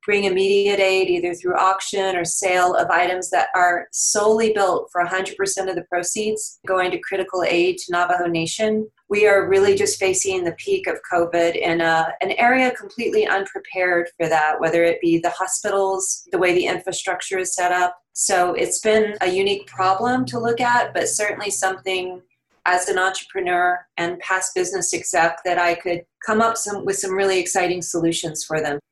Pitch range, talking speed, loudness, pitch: 175-205 Hz, 180 wpm, -20 LUFS, 185 Hz